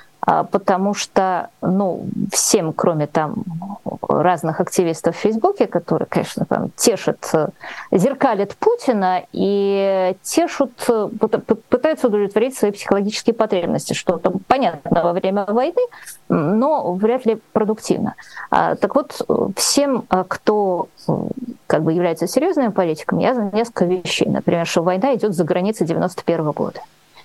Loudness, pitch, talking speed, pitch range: -19 LUFS, 200 Hz, 115 wpm, 180-235 Hz